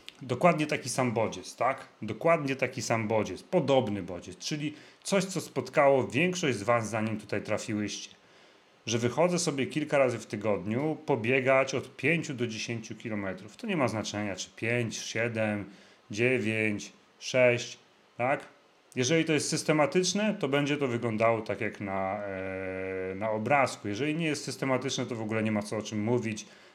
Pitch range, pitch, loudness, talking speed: 110-140 Hz, 120 Hz, -29 LUFS, 155 wpm